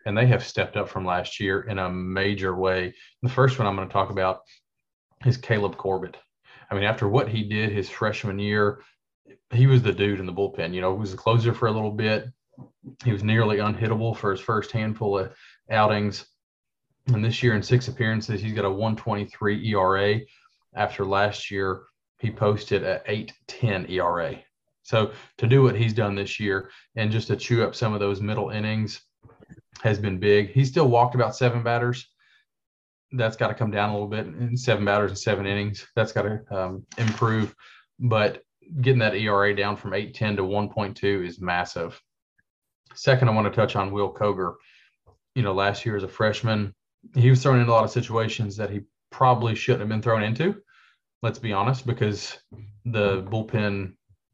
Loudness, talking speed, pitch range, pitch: -24 LUFS, 190 wpm, 100-120 Hz, 105 Hz